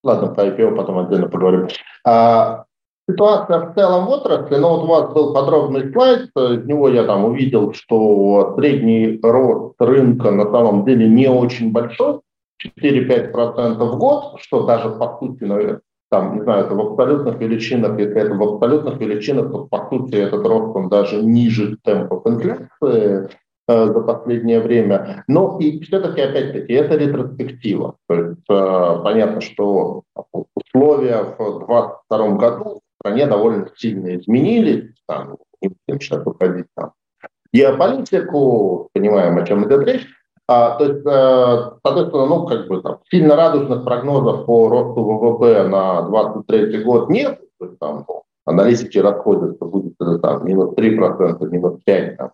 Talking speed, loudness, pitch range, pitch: 150 wpm, -16 LUFS, 105-145 Hz, 120 Hz